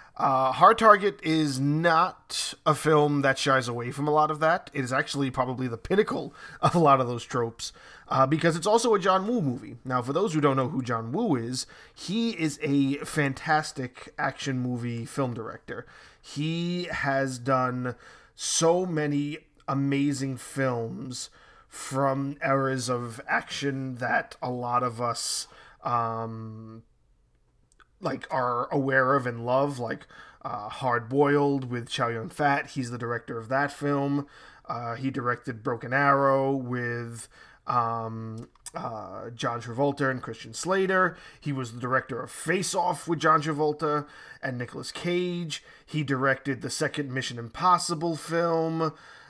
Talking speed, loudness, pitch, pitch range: 150 wpm, -27 LUFS, 135 Hz, 125-155 Hz